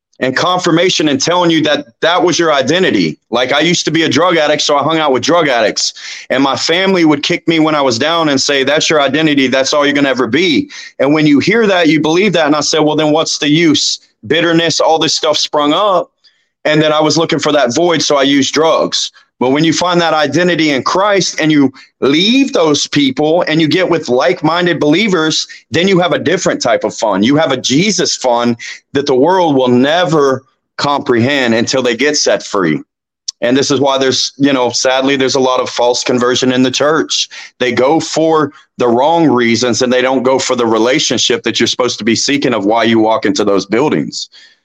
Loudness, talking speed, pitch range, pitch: -11 LUFS, 225 wpm, 130-160 Hz, 150 Hz